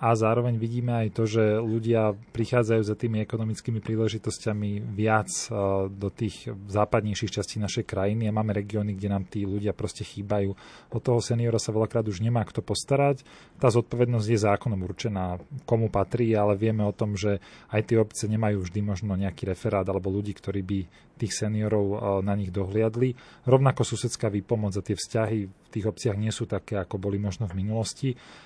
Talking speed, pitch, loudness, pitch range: 175 wpm, 110 Hz, -27 LUFS, 100-115 Hz